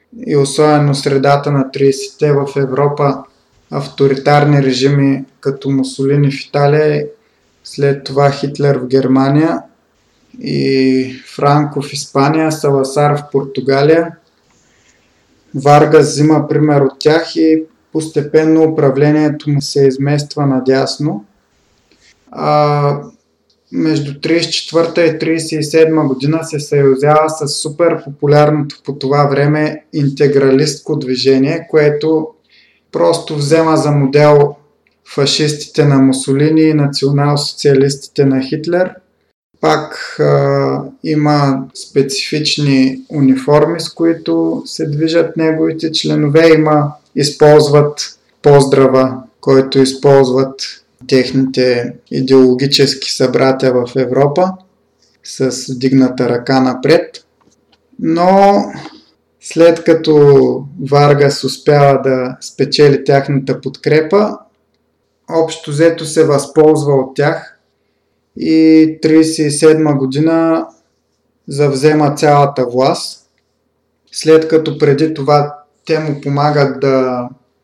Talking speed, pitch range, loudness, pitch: 90 wpm, 135-155 Hz, -12 LUFS, 145 Hz